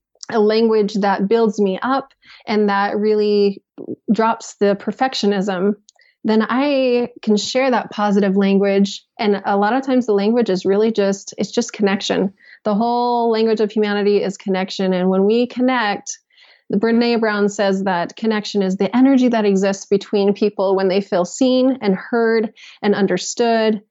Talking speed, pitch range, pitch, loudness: 160 wpm, 200-230 Hz, 210 Hz, -17 LUFS